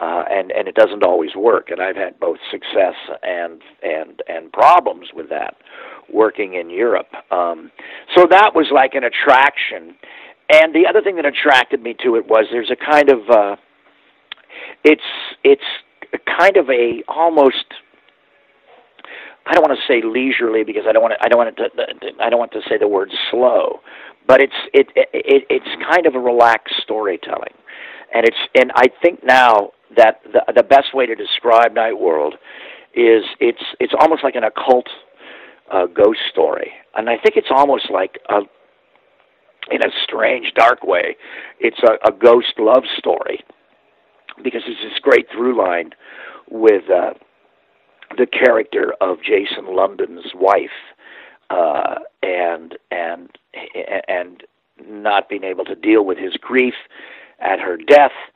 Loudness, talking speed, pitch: -15 LUFS, 165 wpm, 390 Hz